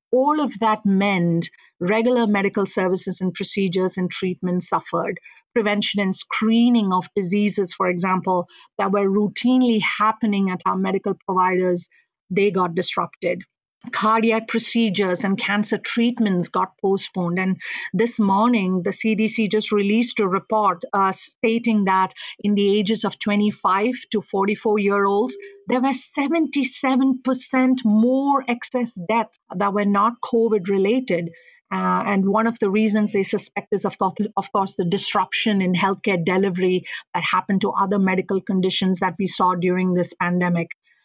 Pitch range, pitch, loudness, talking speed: 185-220 Hz, 200 Hz, -21 LUFS, 145 wpm